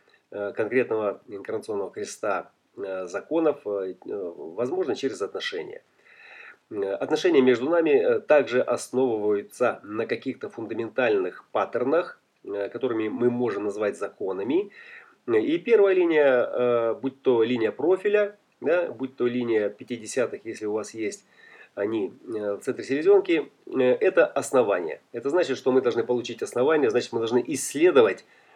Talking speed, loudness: 115 wpm, -25 LUFS